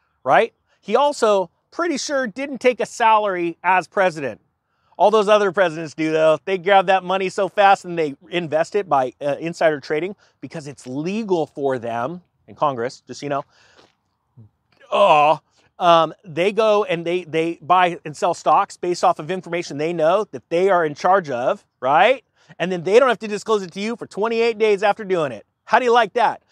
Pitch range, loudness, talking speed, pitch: 155-210 Hz, -19 LUFS, 195 wpm, 180 Hz